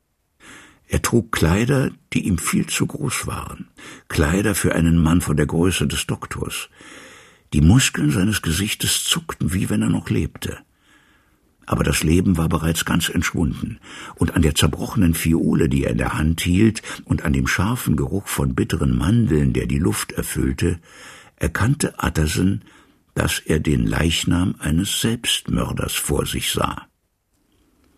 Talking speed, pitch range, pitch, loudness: 150 wpm, 80-95 Hz, 85 Hz, -20 LUFS